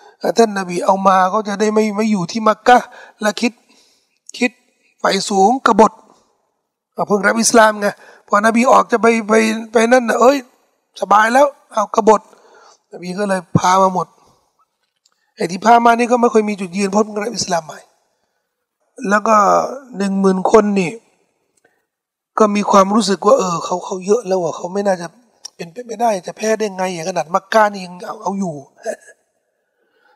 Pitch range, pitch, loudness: 195-235 Hz, 215 Hz, -15 LUFS